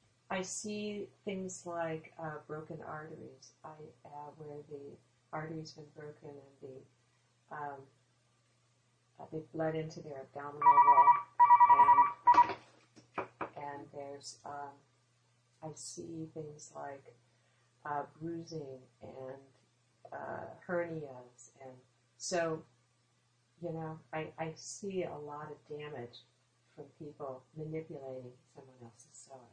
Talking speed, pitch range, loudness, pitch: 110 wpm, 125-160 Hz, -32 LUFS, 145 Hz